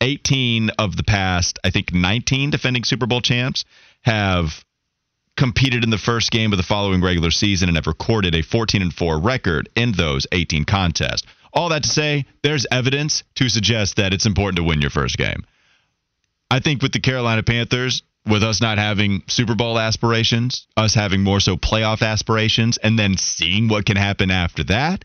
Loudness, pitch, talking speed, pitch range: -18 LUFS, 110 Hz, 185 wpm, 95-120 Hz